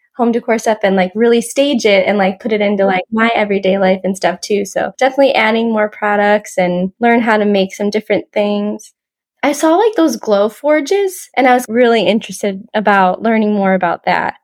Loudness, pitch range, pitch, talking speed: -13 LUFS, 195-235 Hz, 215 Hz, 205 wpm